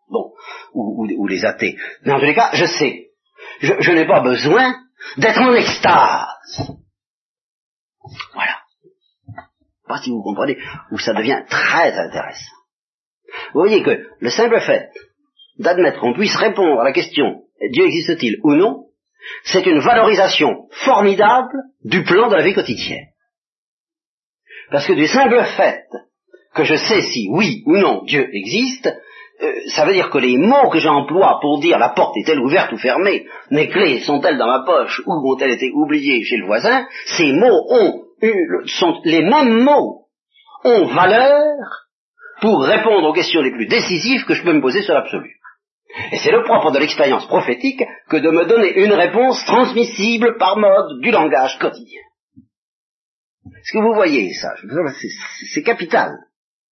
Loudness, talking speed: -15 LUFS, 160 wpm